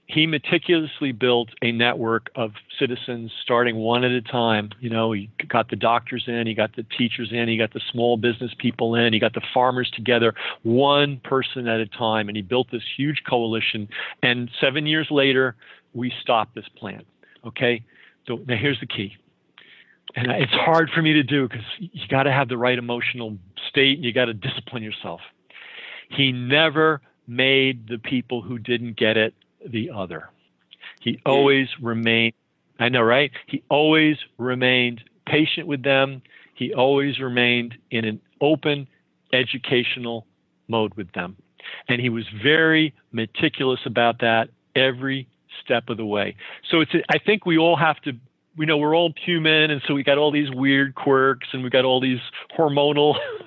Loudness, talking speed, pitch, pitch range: -21 LUFS, 175 wpm, 125 Hz, 115-140 Hz